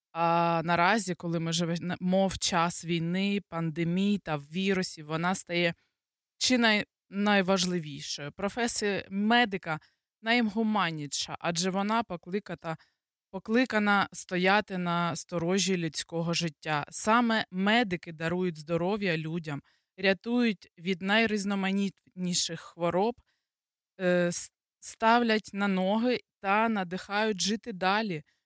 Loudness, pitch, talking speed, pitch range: -28 LUFS, 185 Hz, 95 wpm, 170-205 Hz